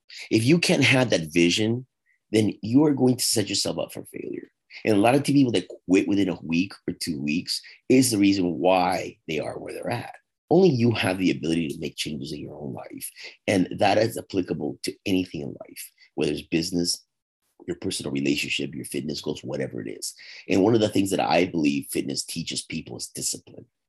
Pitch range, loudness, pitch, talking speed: 85-125 Hz, -24 LUFS, 100 Hz, 210 wpm